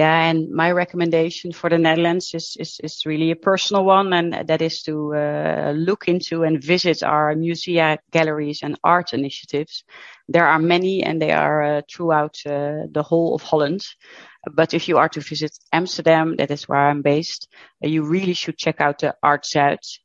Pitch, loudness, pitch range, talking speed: 160 Hz, -19 LUFS, 150-170 Hz, 185 wpm